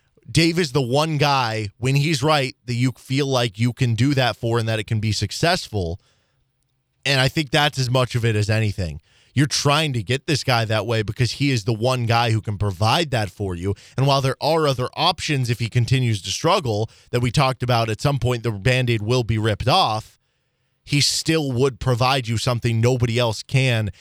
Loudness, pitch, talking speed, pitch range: -20 LUFS, 125 Hz, 215 wpm, 110-135 Hz